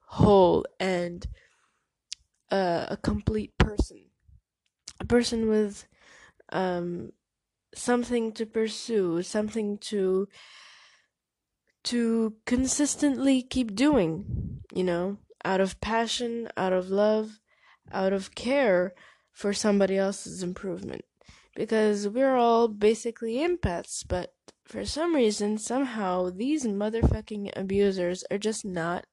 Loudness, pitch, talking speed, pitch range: -27 LUFS, 210 Hz, 105 wpm, 190-235 Hz